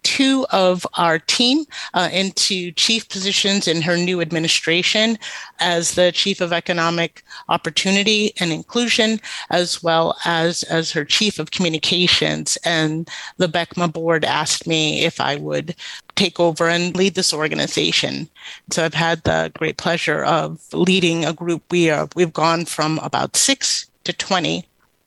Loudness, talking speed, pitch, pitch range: -18 LUFS, 150 wpm, 170 Hz, 165-190 Hz